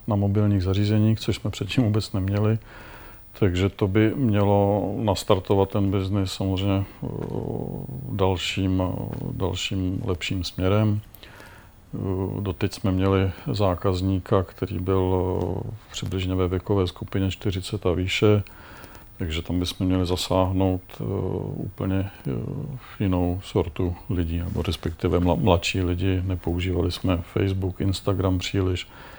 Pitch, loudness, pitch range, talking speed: 95 Hz, -25 LUFS, 90-105 Hz, 105 wpm